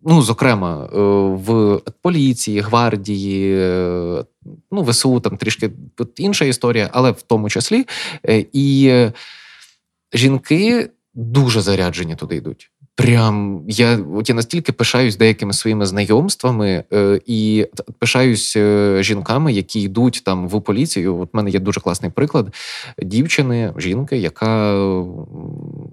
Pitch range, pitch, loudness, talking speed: 100-130 Hz, 110 Hz, -16 LUFS, 110 wpm